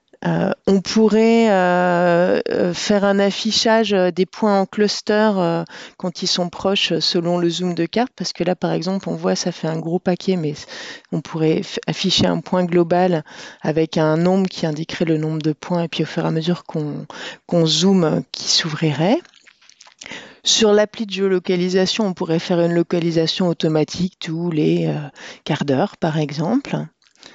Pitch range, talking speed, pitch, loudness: 165-195 Hz, 170 wpm, 175 Hz, -18 LUFS